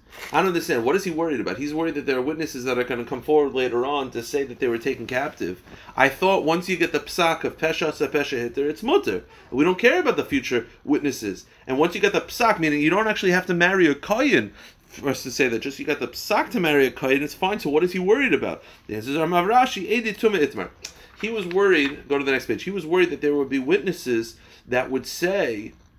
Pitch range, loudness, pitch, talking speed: 135-190 Hz, -22 LUFS, 155 Hz, 255 wpm